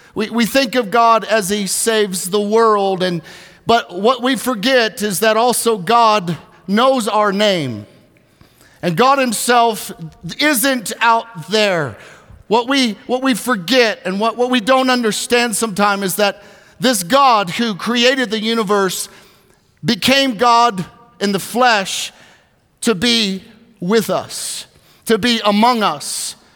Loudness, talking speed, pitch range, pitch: -15 LUFS, 140 wpm, 200-240 Hz, 225 Hz